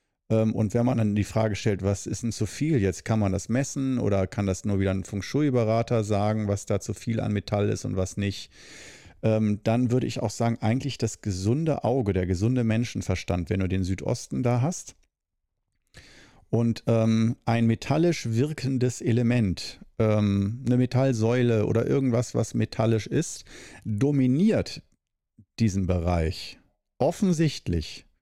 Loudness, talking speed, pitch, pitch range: -26 LUFS, 150 wpm, 110 Hz, 100-120 Hz